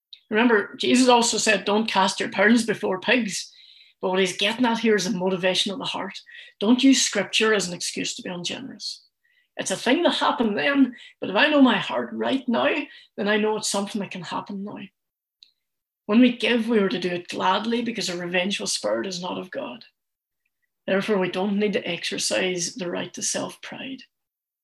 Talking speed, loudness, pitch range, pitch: 195 wpm, -22 LUFS, 190-245 Hz, 215 Hz